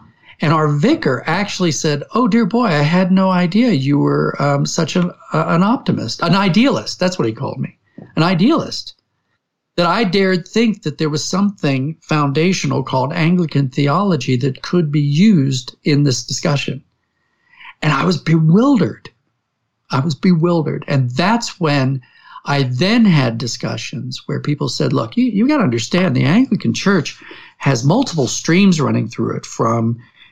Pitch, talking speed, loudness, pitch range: 155 Hz, 160 wpm, -16 LUFS, 140-185 Hz